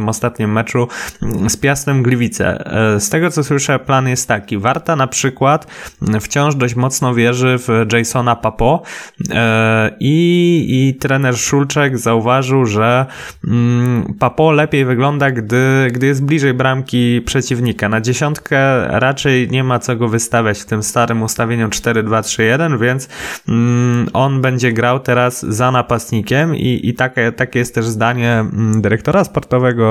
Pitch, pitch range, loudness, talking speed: 125 Hz, 115-135 Hz, -14 LUFS, 140 wpm